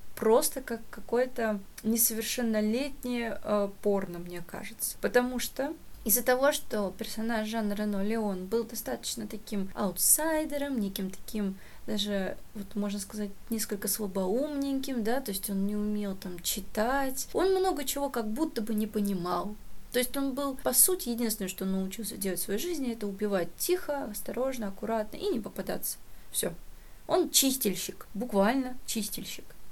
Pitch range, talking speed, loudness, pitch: 205-260 Hz, 145 wpm, -30 LUFS, 225 Hz